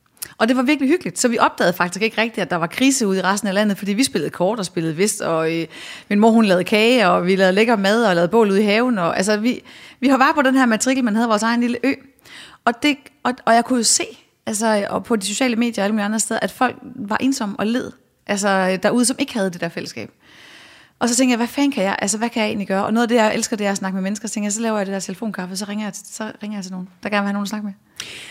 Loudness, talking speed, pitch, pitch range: -18 LUFS, 305 wpm, 215 Hz, 195-240 Hz